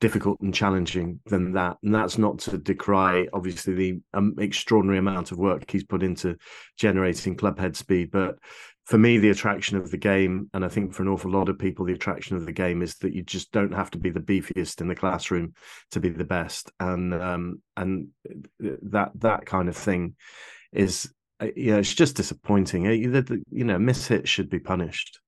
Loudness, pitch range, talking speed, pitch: -25 LUFS, 90-100 Hz, 200 wpm, 95 Hz